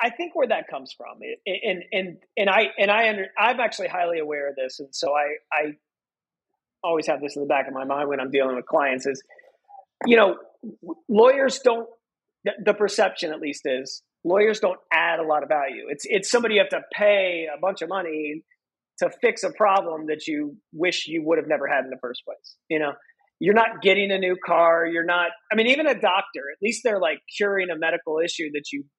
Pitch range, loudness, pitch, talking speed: 150-220 Hz, -23 LUFS, 180 Hz, 220 wpm